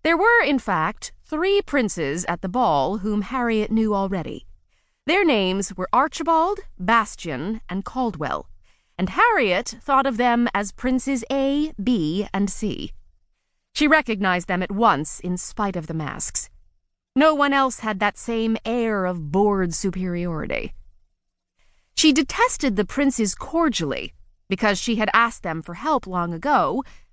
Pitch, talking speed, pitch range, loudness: 215 Hz, 145 wpm, 180-270 Hz, -22 LUFS